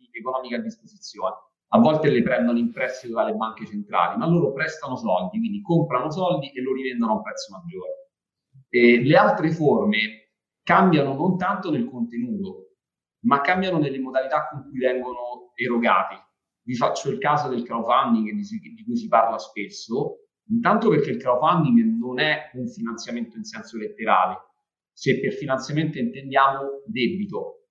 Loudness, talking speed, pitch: -22 LUFS, 150 wpm, 155 Hz